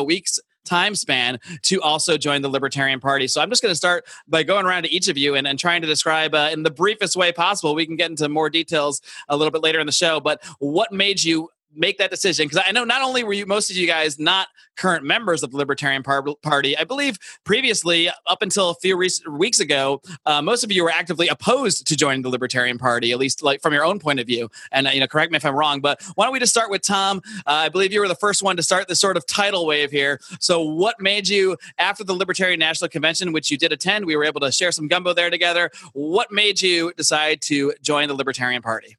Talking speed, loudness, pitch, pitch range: 255 wpm, -19 LUFS, 165 Hz, 145-190 Hz